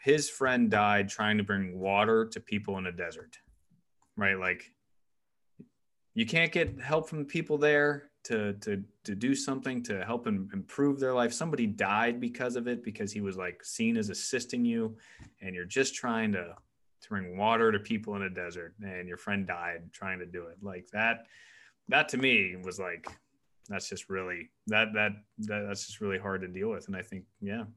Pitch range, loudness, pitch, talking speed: 95-135 Hz, -31 LUFS, 105 Hz, 195 wpm